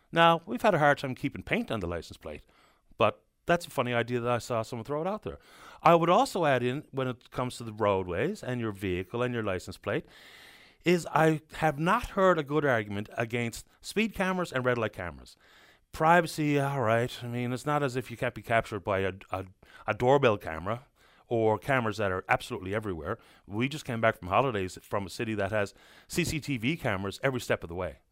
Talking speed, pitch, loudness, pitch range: 215 wpm, 125 Hz, -29 LUFS, 110-150 Hz